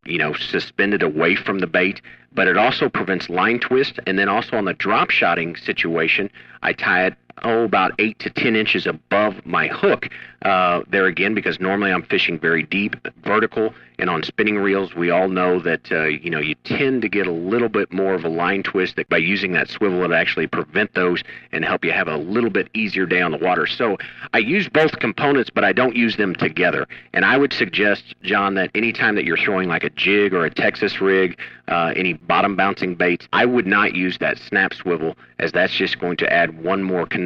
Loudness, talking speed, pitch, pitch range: -19 LUFS, 220 wpm, 95 Hz, 90-110 Hz